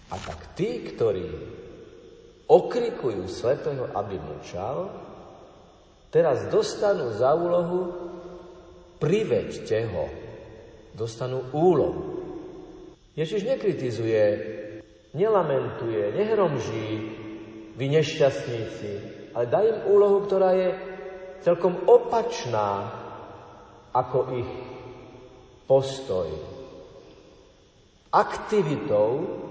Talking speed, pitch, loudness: 70 wpm, 175 Hz, -25 LUFS